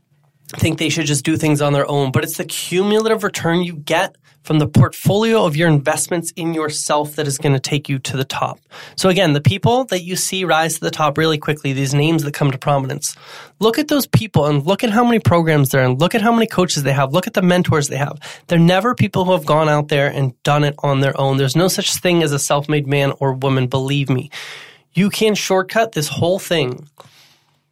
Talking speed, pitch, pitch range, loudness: 240 wpm, 155 Hz, 140-180 Hz, -17 LUFS